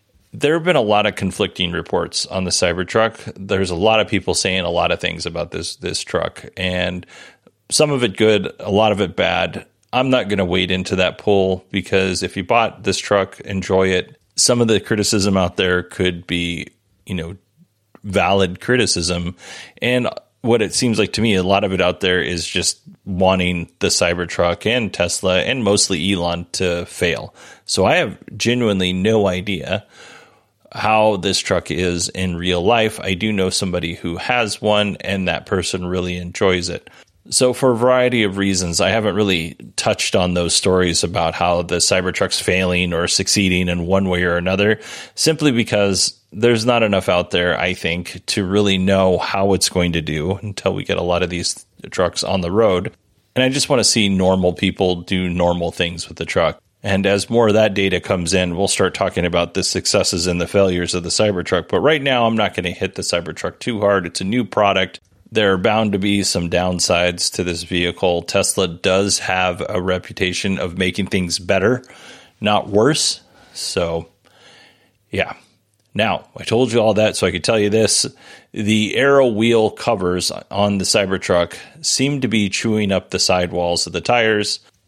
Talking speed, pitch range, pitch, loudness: 190 wpm, 90-105 Hz, 95 Hz, -17 LUFS